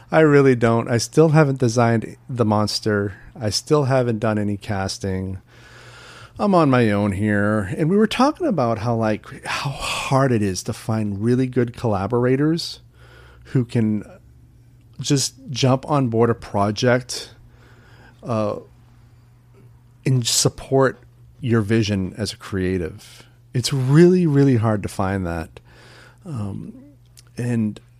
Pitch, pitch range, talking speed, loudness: 120 Hz, 105-130 Hz, 130 wpm, -20 LUFS